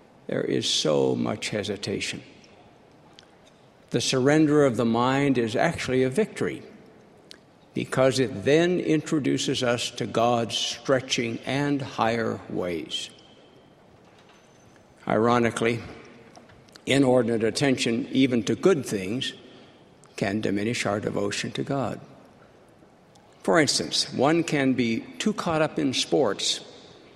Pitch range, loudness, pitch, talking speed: 115-140 Hz, -25 LUFS, 125 Hz, 105 wpm